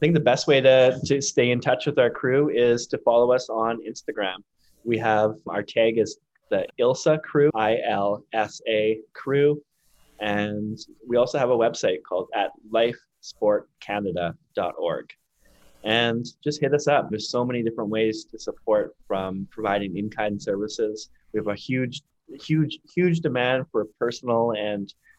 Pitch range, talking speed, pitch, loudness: 110-145 Hz, 160 wpm, 120 Hz, -24 LUFS